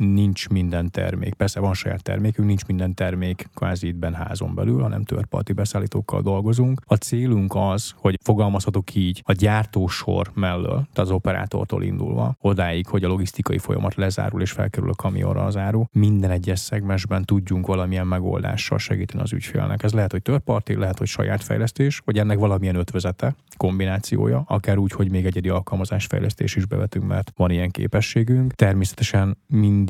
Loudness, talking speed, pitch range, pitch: -22 LUFS, 160 wpm, 95-115 Hz, 100 Hz